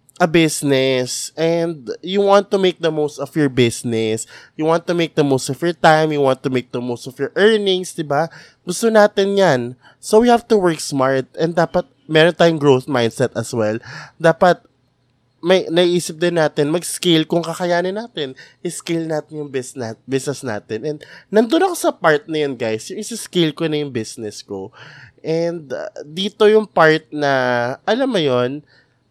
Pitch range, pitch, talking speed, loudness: 130-175 Hz, 155 Hz, 175 wpm, -17 LUFS